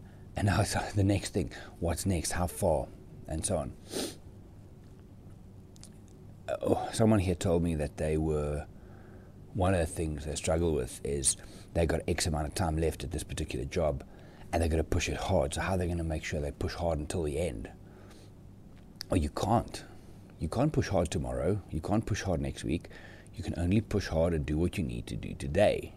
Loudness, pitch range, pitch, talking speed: -32 LUFS, 80-100 Hz, 90 Hz, 205 wpm